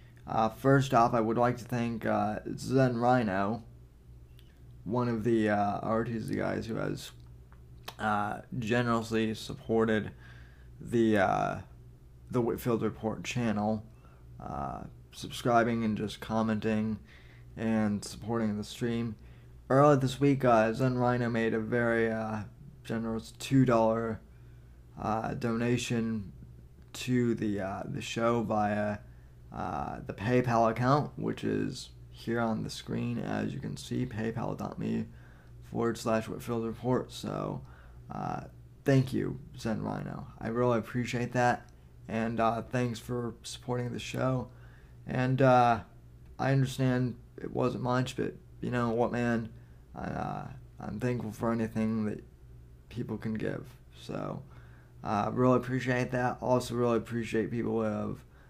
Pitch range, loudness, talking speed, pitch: 95-120 Hz, -31 LUFS, 130 wpm, 115 Hz